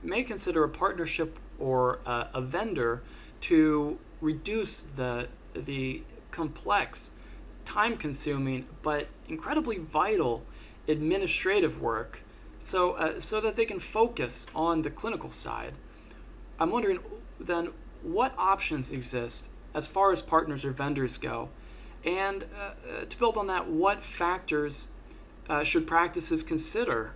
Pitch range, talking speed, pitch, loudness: 140-210 Hz, 125 wpm, 165 Hz, -29 LUFS